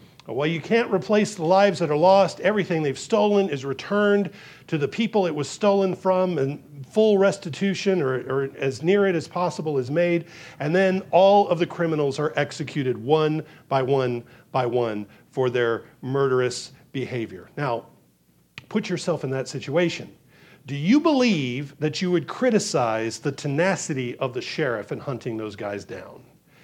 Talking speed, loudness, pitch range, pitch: 165 wpm, -23 LUFS, 135-185 Hz, 155 Hz